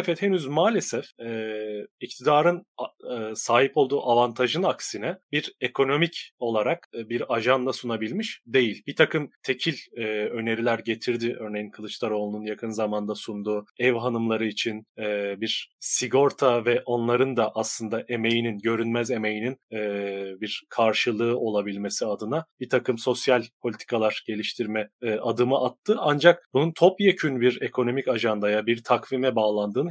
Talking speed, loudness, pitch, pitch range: 130 wpm, -25 LUFS, 120 Hz, 110-130 Hz